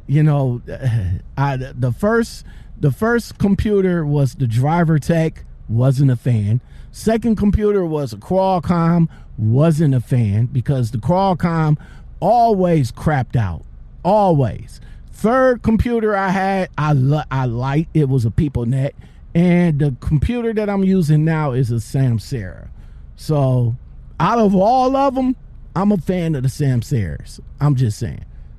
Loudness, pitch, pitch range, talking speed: -17 LUFS, 150 Hz, 125-185 Hz, 145 wpm